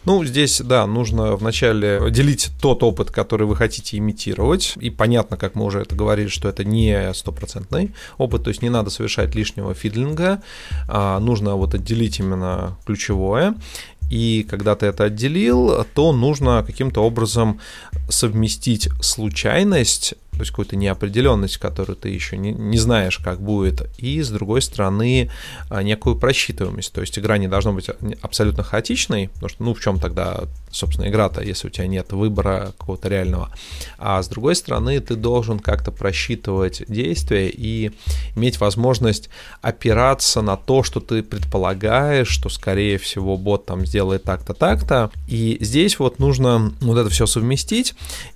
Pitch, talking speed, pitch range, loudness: 105 Hz, 150 wpm, 95-115 Hz, -19 LUFS